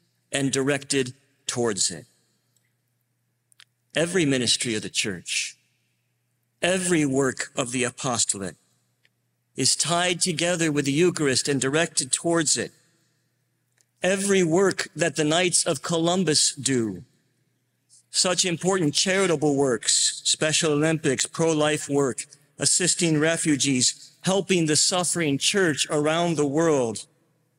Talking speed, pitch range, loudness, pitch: 105 wpm, 125-170 Hz, -22 LUFS, 150 Hz